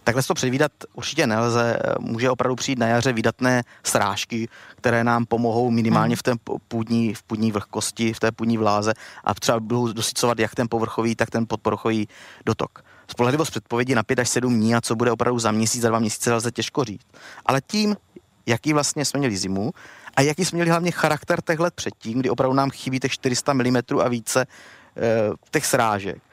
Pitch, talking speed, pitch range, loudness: 120 Hz, 185 wpm, 115-130 Hz, -22 LUFS